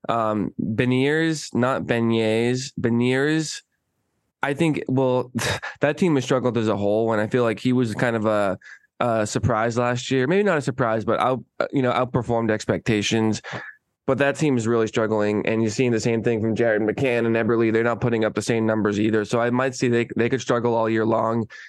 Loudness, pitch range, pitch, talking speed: -22 LUFS, 110-130 Hz, 120 Hz, 205 wpm